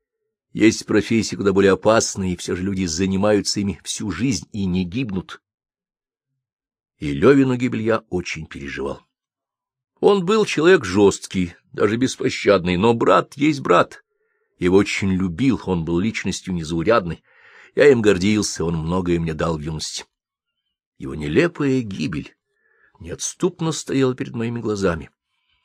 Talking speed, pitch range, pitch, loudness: 130 wpm, 90-135 Hz, 105 Hz, -20 LUFS